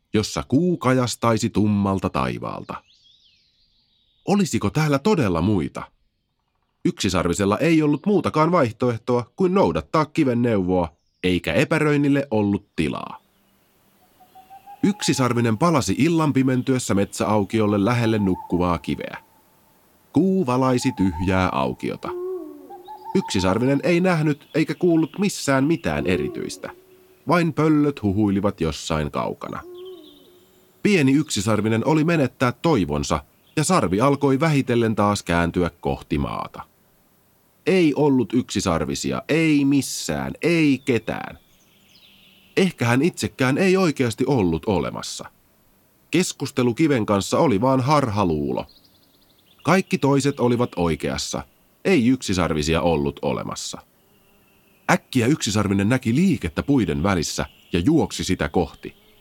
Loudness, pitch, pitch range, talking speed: -21 LUFS, 125 Hz, 95-155 Hz, 100 wpm